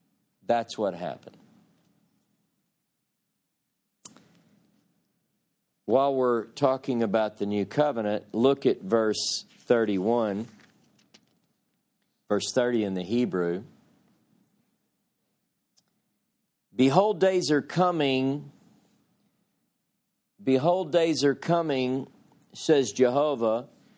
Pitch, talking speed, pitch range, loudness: 130 Hz, 75 wpm, 115-150 Hz, -26 LUFS